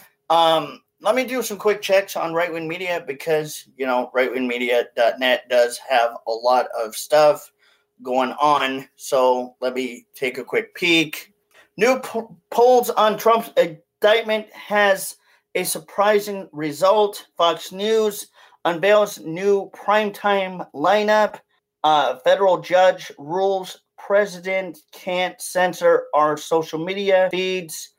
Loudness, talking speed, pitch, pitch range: -20 LUFS, 120 wpm, 180 Hz, 150-205 Hz